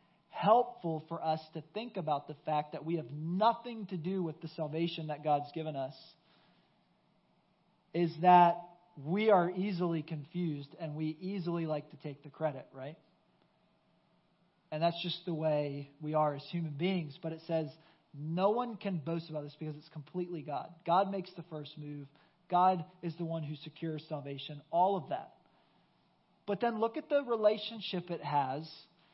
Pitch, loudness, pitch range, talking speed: 165 Hz, -34 LUFS, 155-180 Hz, 170 wpm